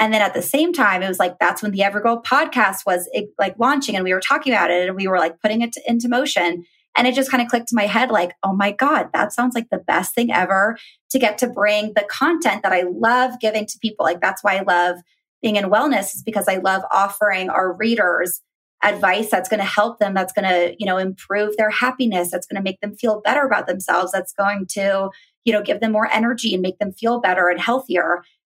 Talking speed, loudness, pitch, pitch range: 245 wpm, -19 LUFS, 210 Hz, 190-235 Hz